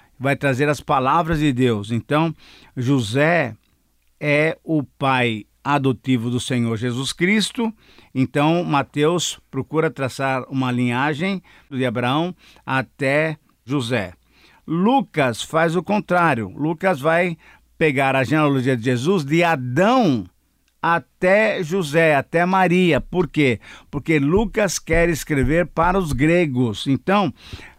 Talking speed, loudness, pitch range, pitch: 115 wpm, -20 LUFS, 130-170 Hz, 150 Hz